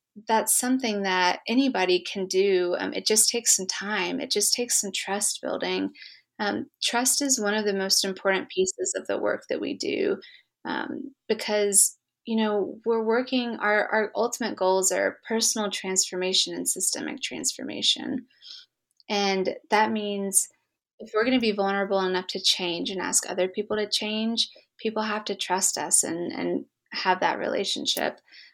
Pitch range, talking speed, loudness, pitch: 195-235 Hz, 160 wpm, -25 LUFS, 210 Hz